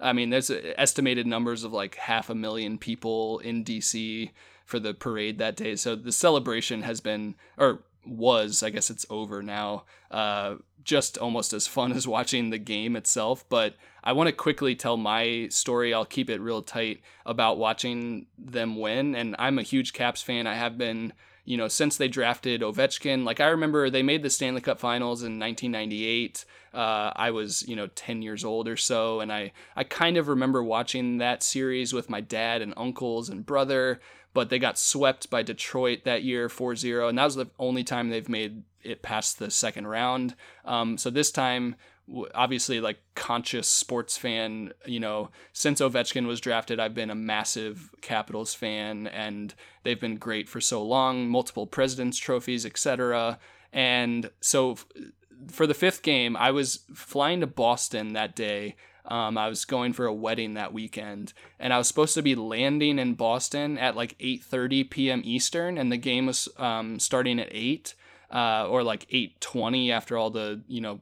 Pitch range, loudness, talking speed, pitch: 110-130 Hz, -27 LUFS, 185 wpm, 120 Hz